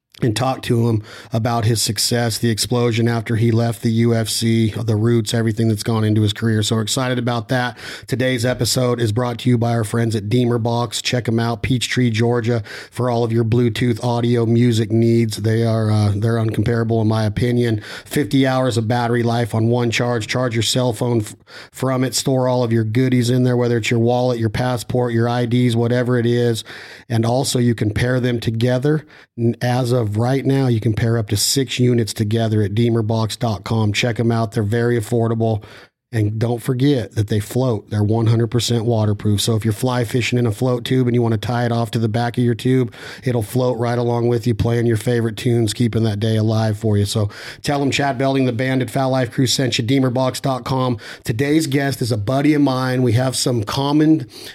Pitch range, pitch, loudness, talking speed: 115-125 Hz, 120 Hz, -18 LUFS, 210 wpm